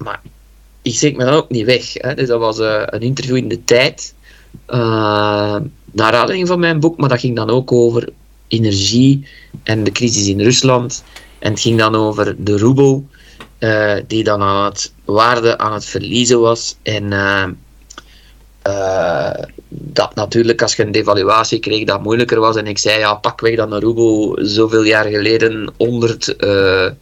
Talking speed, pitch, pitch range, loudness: 175 wpm, 115 Hz, 105-125 Hz, -14 LUFS